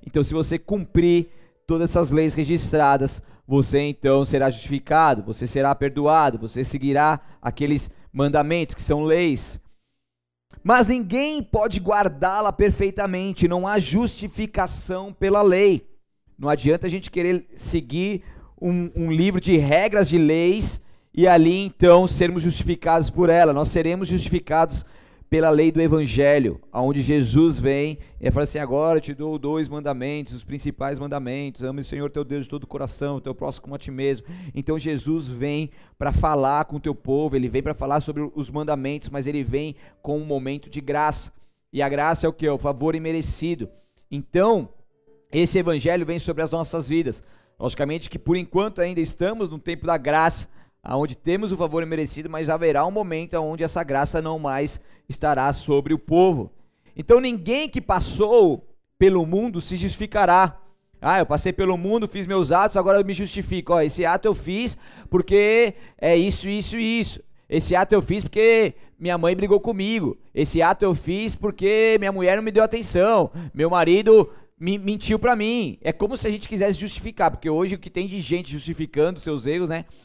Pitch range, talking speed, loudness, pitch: 145-190 Hz, 175 wpm, -21 LUFS, 165 Hz